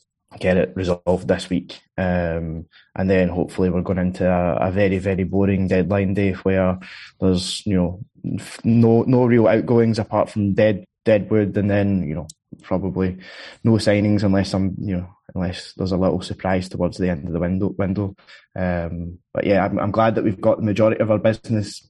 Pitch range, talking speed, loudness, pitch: 90-105 Hz, 190 wpm, -20 LUFS, 95 Hz